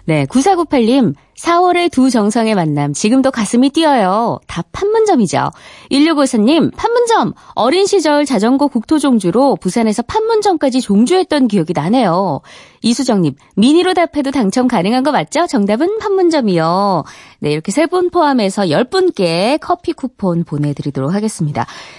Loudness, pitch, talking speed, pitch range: -13 LUFS, 255 Hz, 310 characters per minute, 195-320 Hz